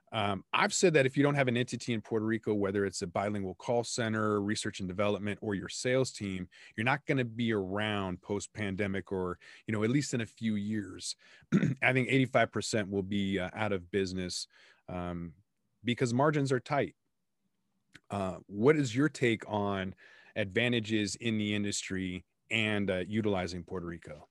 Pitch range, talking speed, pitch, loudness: 100-120 Hz, 175 wpm, 105 Hz, -32 LUFS